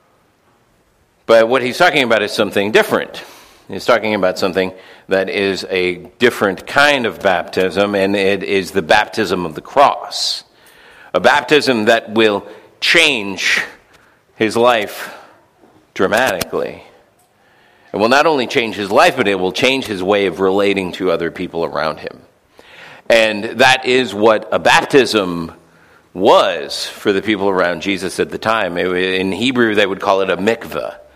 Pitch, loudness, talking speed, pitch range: 100 Hz, -15 LUFS, 150 wpm, 95-115 Hz